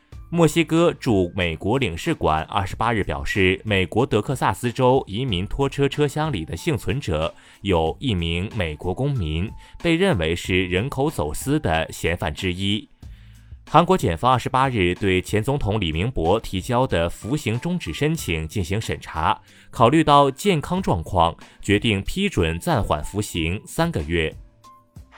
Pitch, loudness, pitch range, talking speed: 110 Hz, -22 LUFS, 90-140 Hz, 235 characters per minute